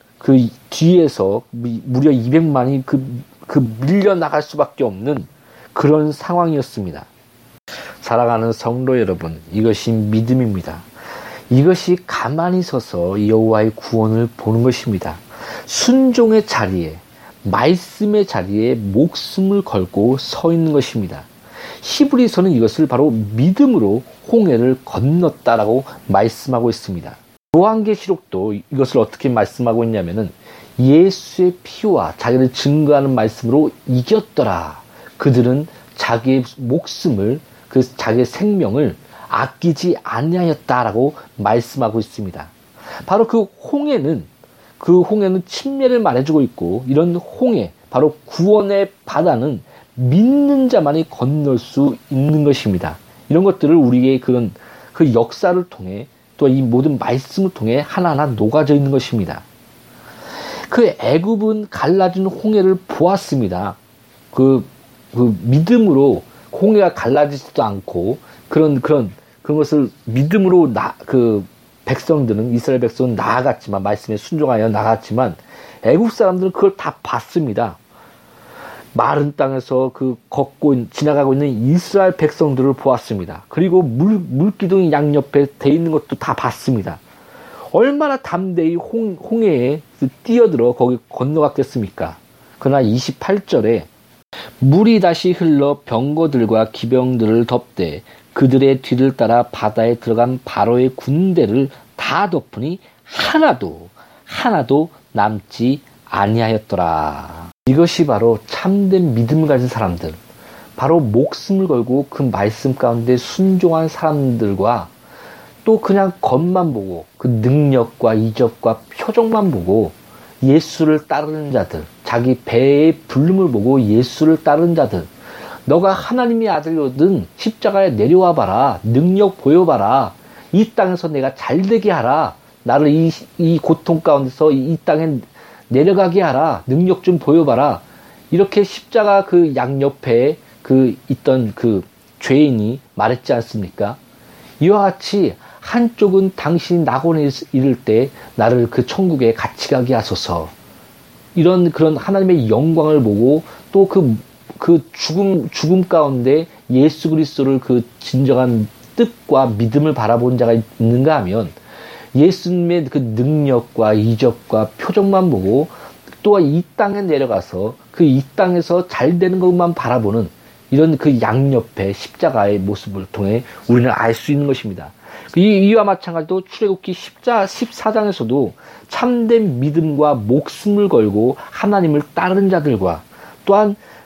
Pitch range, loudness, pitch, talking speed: 120-175 Hz, -15 LUFS, 140 Hz, 275 characters per minute